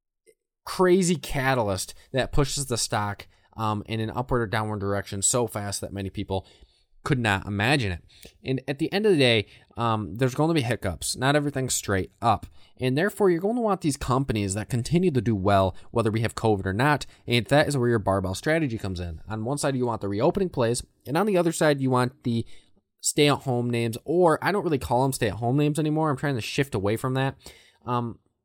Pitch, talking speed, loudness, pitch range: 120 Hz, 225 wpm, -25 LUFS, 105-145 Hz